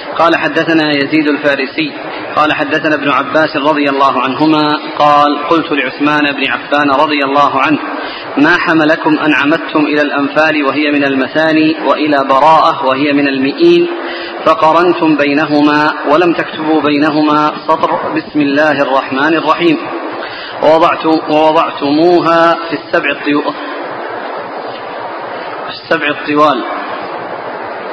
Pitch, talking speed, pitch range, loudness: 150 Hz, 105 wpm, 145-155 Hz, -11 LUFS